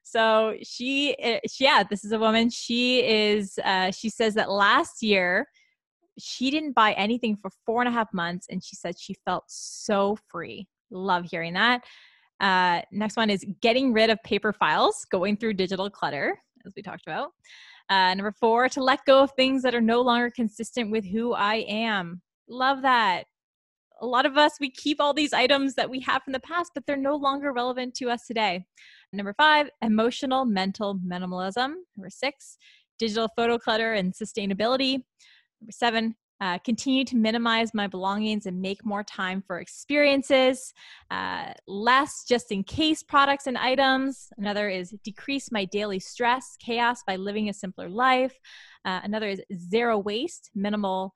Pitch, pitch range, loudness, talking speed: 225 Hz, 200-260 Hz, -25 LUFS, 170 wpm